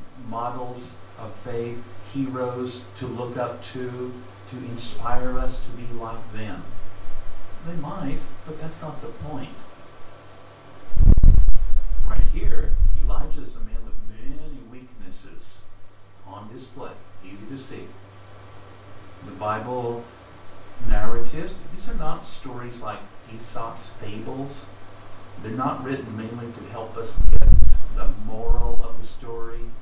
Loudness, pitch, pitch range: -29 LUFS, 110 Hz, 95-120 Hz